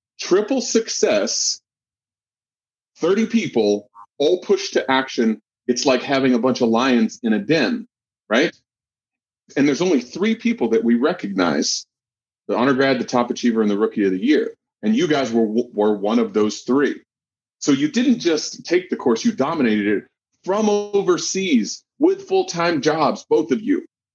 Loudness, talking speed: -19 LUFS, 165 wpm